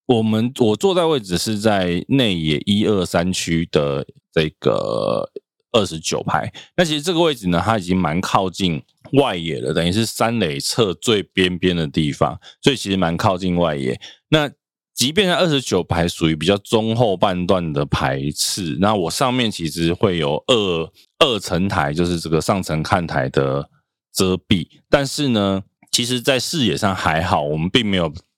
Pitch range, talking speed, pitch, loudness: 85-115 Hz, 250 characters per minute, 95 Hz, -19 LUFS